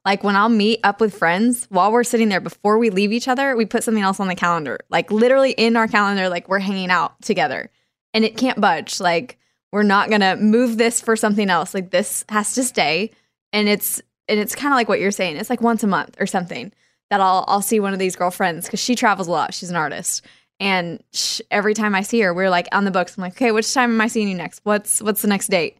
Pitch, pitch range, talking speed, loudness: 210 Hz, 190-230 Hz, 260 wpm, -18 LUFS